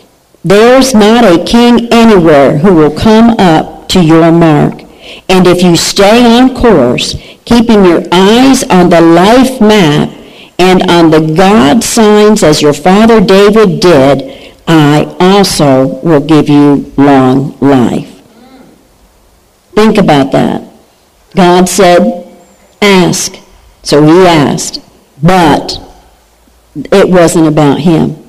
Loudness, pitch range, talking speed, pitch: -5 LUFS, 160-215 Hz, 120 wpm, 180 Hz